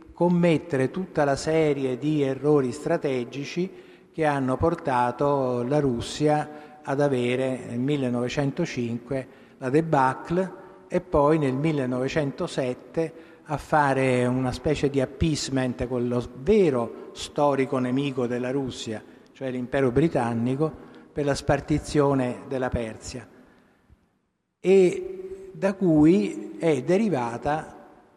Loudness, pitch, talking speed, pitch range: -25 LUFS, 140 Hz, 100 wpm, 125-160 Hz